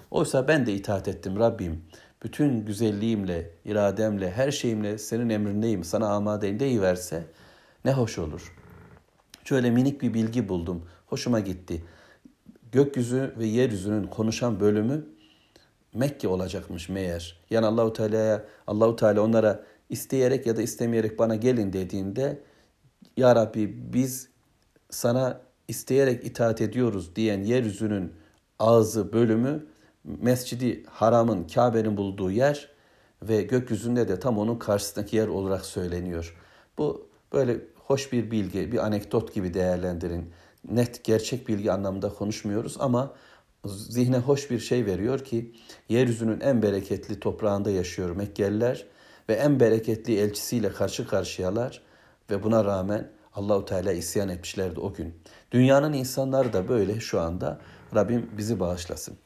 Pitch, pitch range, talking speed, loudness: 110 Hz, 95-120 Hz, 125 wpm, -26 LUFS